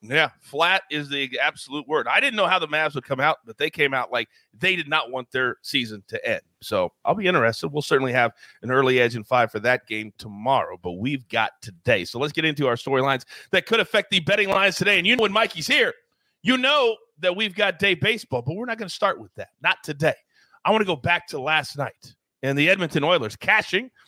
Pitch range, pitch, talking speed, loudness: 130-195 Hz, 155 Hz, 240 wpm, -22 LUFS